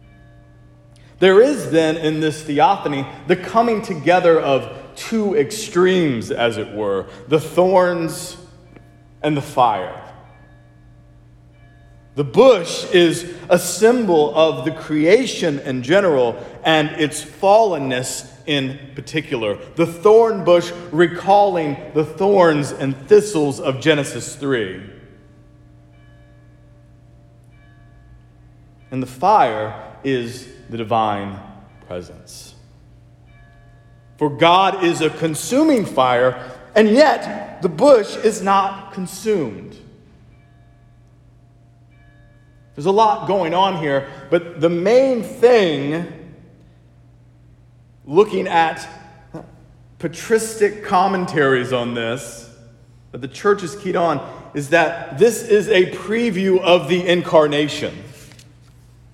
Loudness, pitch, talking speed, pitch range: -17 LUFS, 150 Hz, 100 wpm, 120-180 Hz